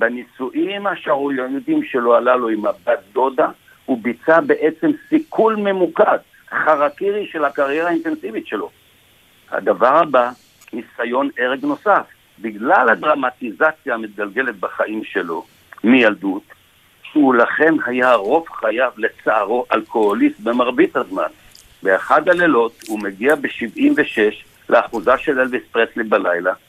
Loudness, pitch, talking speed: -17 LUFS, 155 Hz, 110 wpm